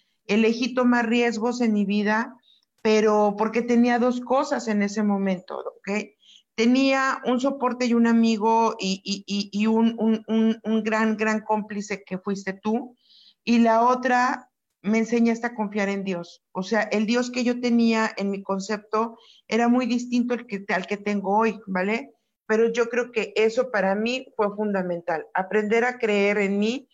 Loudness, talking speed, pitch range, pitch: -23 LUFS, 175 wpm, 205-240 Hz, 220 Hz